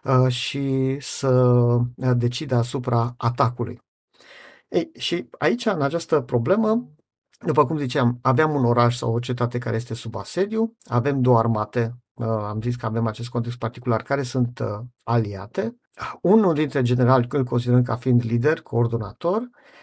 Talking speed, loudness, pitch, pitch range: 140 wpm, -22 LUFS, 125 Hz, 120-145 Hz